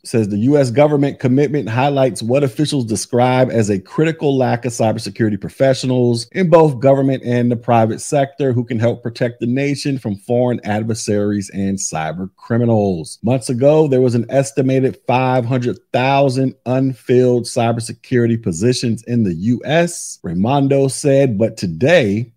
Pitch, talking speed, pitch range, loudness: 125 Hz, 140 wpm, 115-135 Hz, -16 LUFS